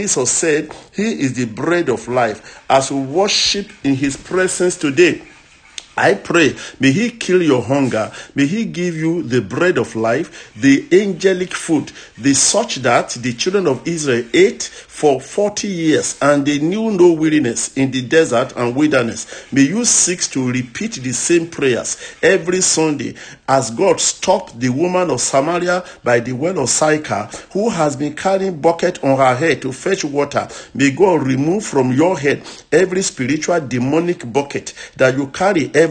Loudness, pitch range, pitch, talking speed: -16 LUFS, 135-185 Hz, 160 Hz, 170 wpm